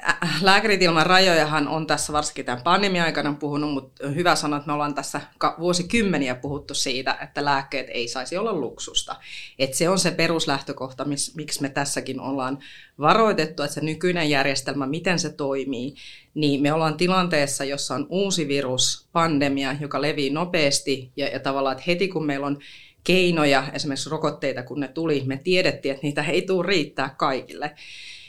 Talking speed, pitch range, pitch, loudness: 165 wpm, 140-165 Hz, 145 Hz, -23 LUFS